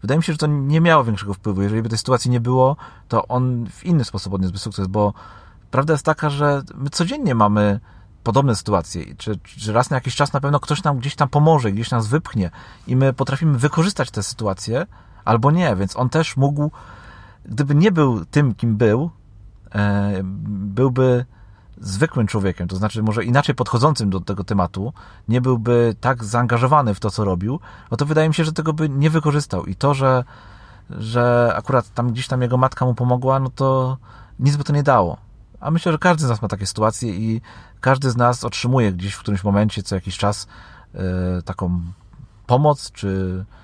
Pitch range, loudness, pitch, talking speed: 100-140 Hz, -19 LUFS, 120 Hz, 190 wpm